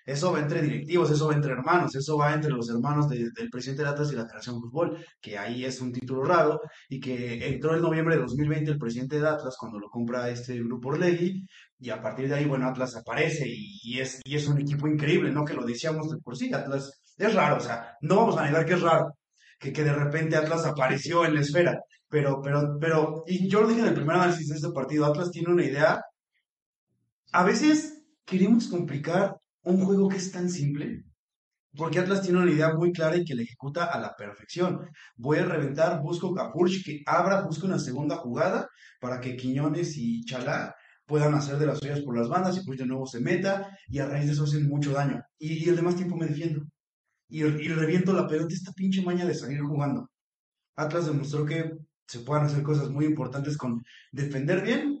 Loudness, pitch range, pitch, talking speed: -27 LUFS, 135-170 Hz, 150 Hz, 220 wpm